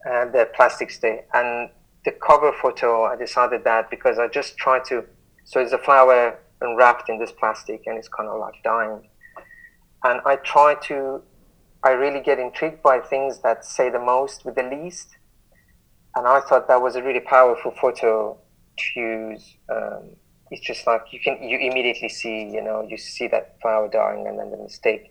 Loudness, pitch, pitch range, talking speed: -21 LUFS, 125 Hz, 115-135 Hz, 190 wpm